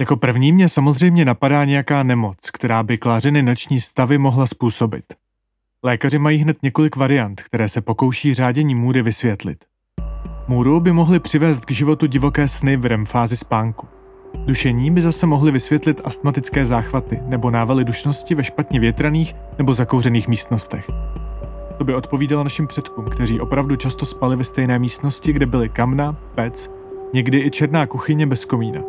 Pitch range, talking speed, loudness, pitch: 125-145 Hz, 155 wpm, -17 LUFS, 135 Hz